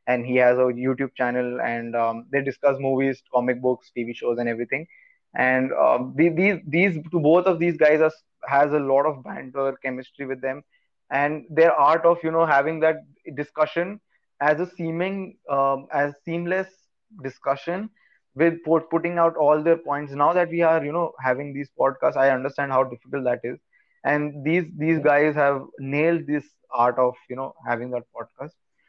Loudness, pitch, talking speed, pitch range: -23 LUFS, 145 Hz, 175 wpm, 130-165 Hz